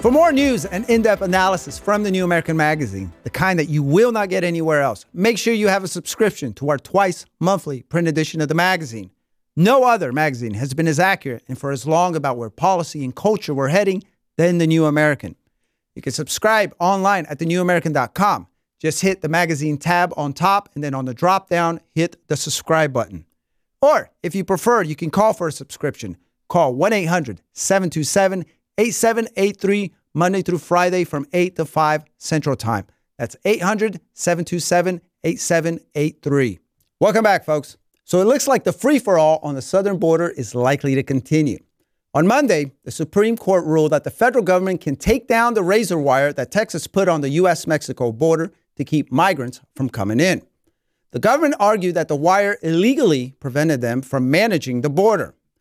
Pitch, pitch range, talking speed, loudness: 165 Hz, 145-190 Hz, 180 wpm, -19 LUFS